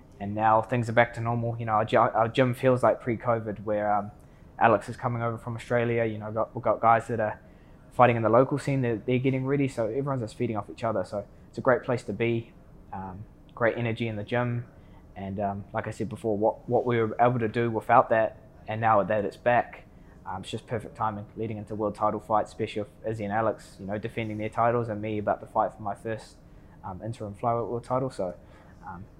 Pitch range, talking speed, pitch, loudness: 105-120 Hz, 240 wpm, 110 Hz, -27 LUFS